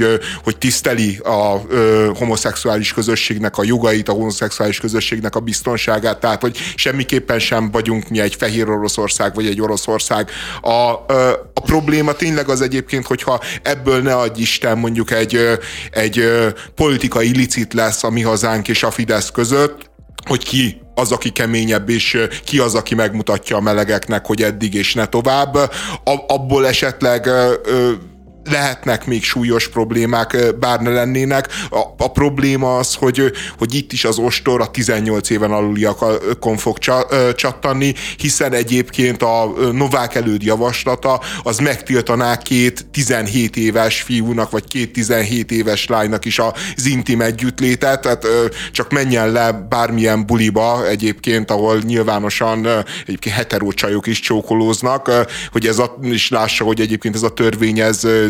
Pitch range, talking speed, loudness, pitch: 110-125 Hz, 140 wpm, -16 LUFS, 115 Hz